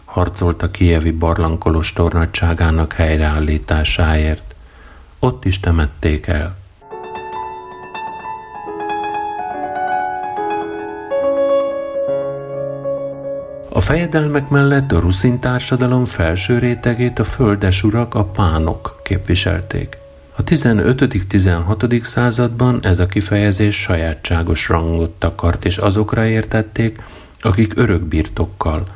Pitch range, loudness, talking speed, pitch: 85-135 Hz, -17 LUFS, 80 wpm, 105 Hz